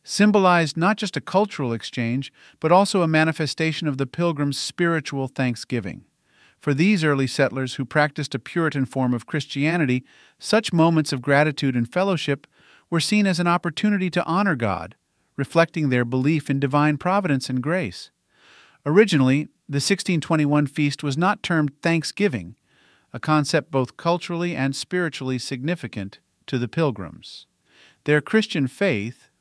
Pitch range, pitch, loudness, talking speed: 135-175 Hz, 150 Hz, -22 LUFS, 140 wpm